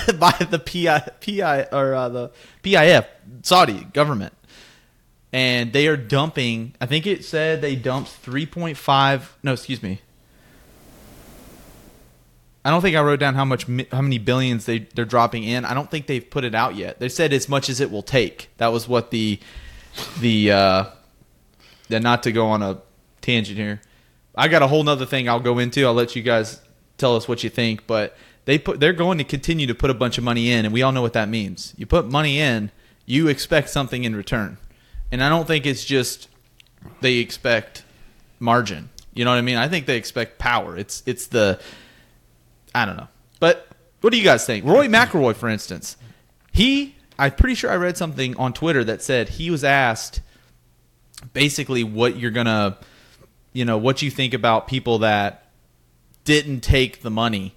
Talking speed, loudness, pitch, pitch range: 190 wpm, -20 LUFS, 125 Hz, 115-140 Hz